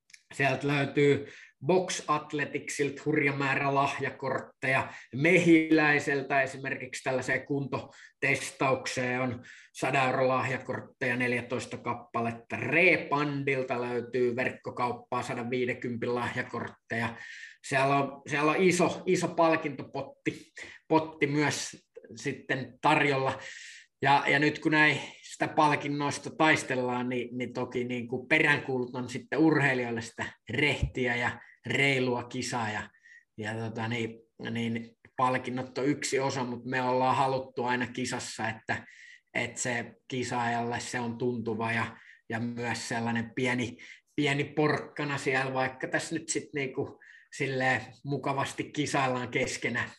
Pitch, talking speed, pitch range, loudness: 130 Hz, 110 wpm, 125-145 Hz, -29 LUFS